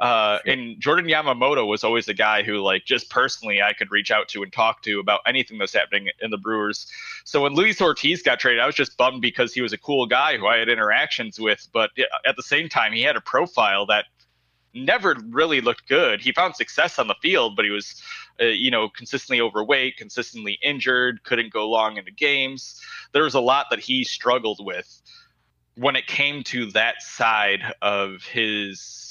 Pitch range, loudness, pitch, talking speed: 105-150 Hz, -21 LUFS, 115 Hz, 205 wpm